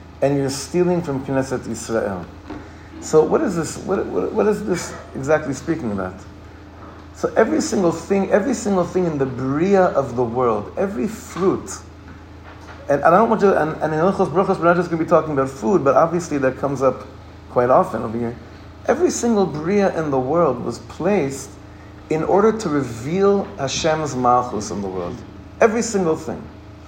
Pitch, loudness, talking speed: 140 Hz, -19 LUFS, 185 wpm